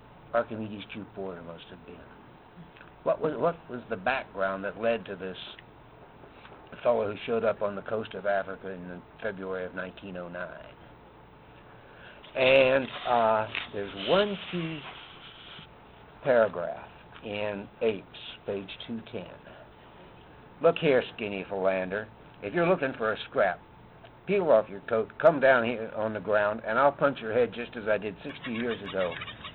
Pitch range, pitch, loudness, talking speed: 95-130 Hz, 105 Hz, -29 LUFS, 145 wpm